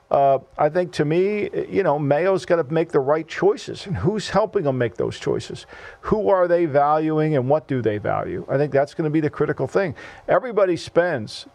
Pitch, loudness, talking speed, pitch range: 155 Hz, -21 LUFS, 215 wpm, 145-180 Hz